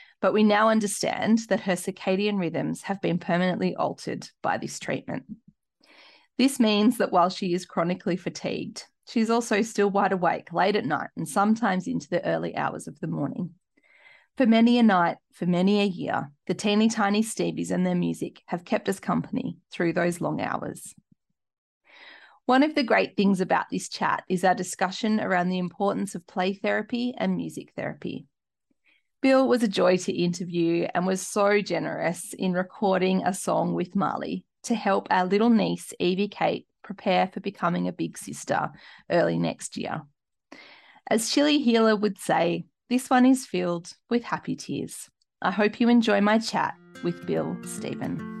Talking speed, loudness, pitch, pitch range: 170 wpm, -25 LUFS, 190 Hz, 175-215 Hz